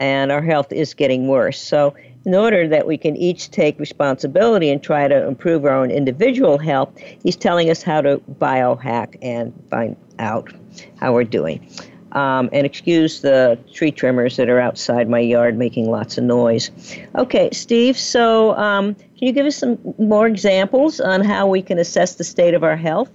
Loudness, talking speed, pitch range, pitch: -17 LUFS, 185 wpm, 130-195 Hz, 155 Hz